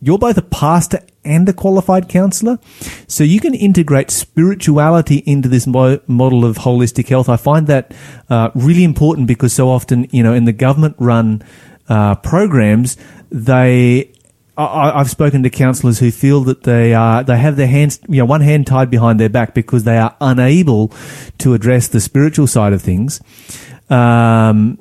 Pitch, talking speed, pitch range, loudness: 130 Hz, 175 wpm, 120-150 Hz, -12 LUFS